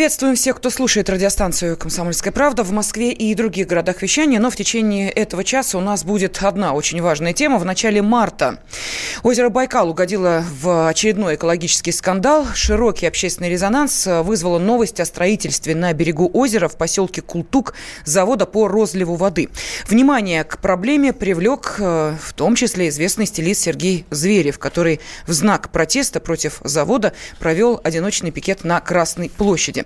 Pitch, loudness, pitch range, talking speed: 190 Hz, -17 LUFS, 170-220 Hz, 150 wpm